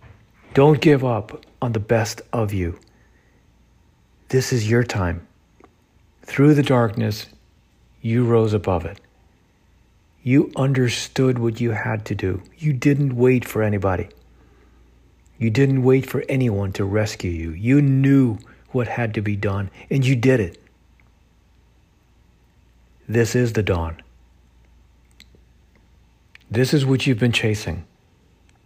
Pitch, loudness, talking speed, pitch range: 110 Hz, -20 LUFS, 125 wpm, 95-125 Hz